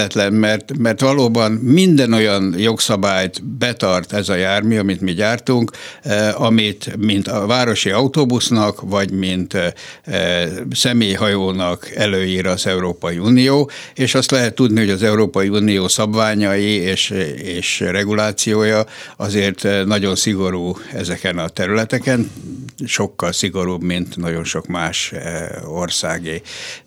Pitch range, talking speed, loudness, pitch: 95-115 Hz, 110 wpm, -17 LUFS, 105 Hz